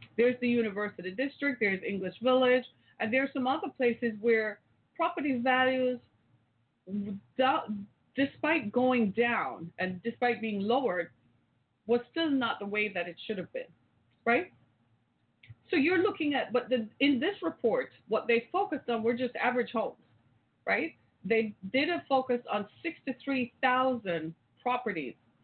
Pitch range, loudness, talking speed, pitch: 200-265 Hz, -30 LUFS, 140 wpm, 235 Hz